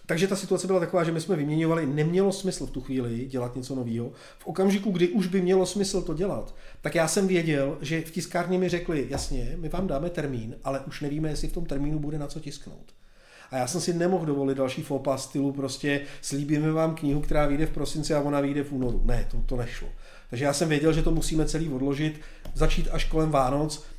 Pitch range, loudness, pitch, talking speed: 140-175 Hz, -27 LUFS, 155 Hz, 225 wpm